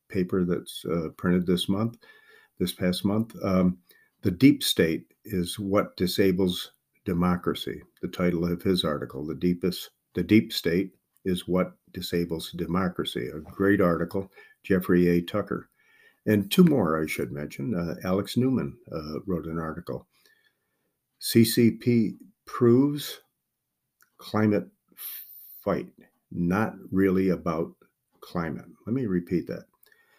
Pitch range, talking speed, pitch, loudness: 90-110 Hz, 125 wpm, 95 Hz, -26 LUFS